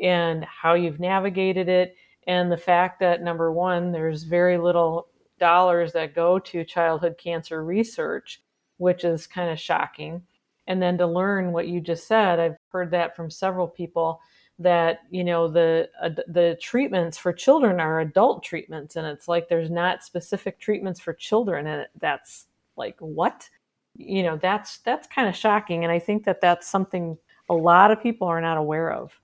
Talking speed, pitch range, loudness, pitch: 175 wpm, 165-185 Hz, -23 LUFS, 175 Hz